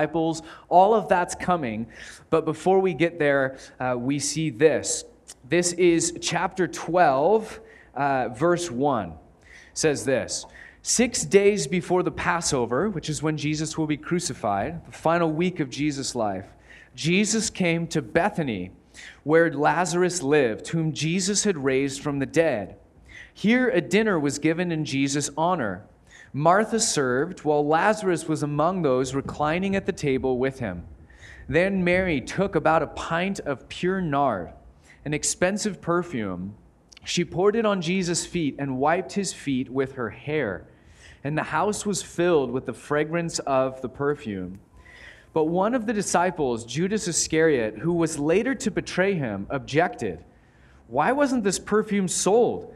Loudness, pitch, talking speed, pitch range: -24 LUFS, 160 Hz, 150 wpm, 140-180 Hz